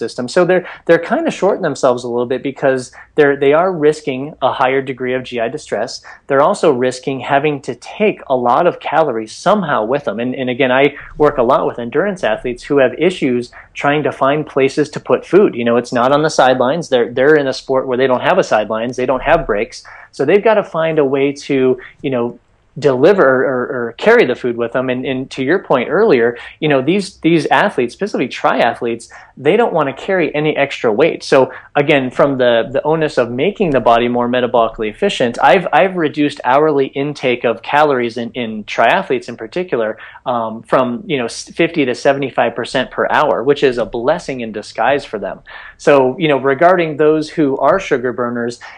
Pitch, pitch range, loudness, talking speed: 135 Hz, 120-150 Hz, -15 LUFS, 205 wpm